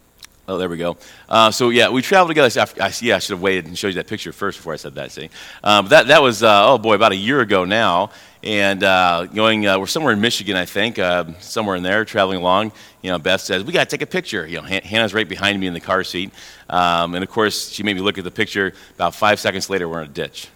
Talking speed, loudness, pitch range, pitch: 280 wpm, -17 LUFS, 90-110 Hz, 100 Hz